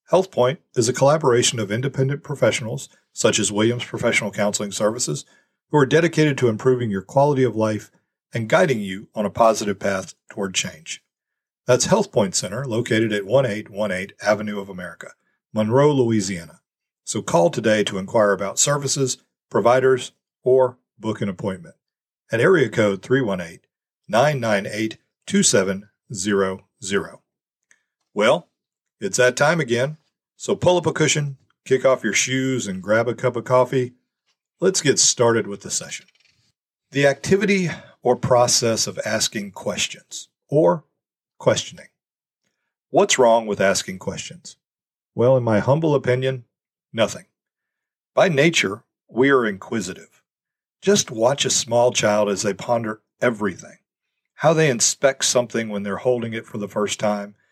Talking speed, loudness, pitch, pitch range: 140 wpm, -20 LUFS, 115 Hz, 105-130 Hz